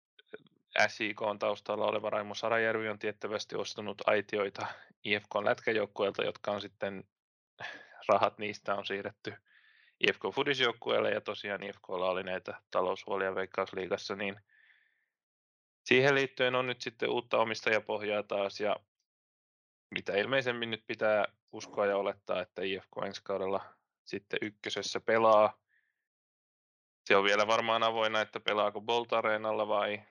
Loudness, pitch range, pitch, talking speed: -32 LUFS, 100-125 Hz, 110 Hz, 125 wpm